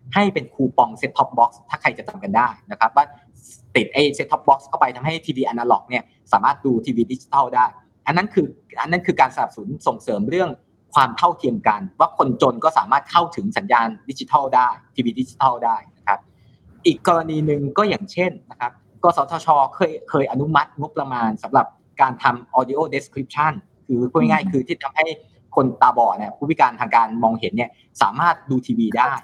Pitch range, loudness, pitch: 125-170 Hz, -20 LUFS, 140 Hz